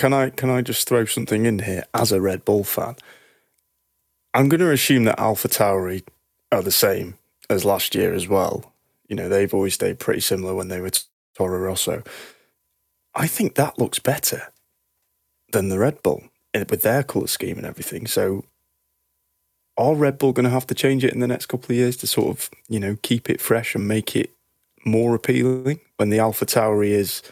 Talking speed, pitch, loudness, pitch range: 200 wpm, 110 Hz, -21 LUFS, 95-125 Hz